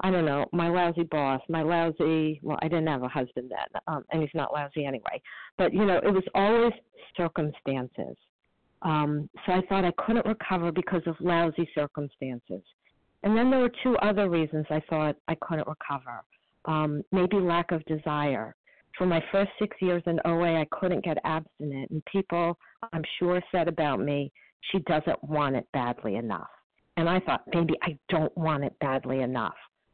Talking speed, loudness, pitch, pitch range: 180 wpm, -28 LUFS, 165 Hz, 150-180 Hz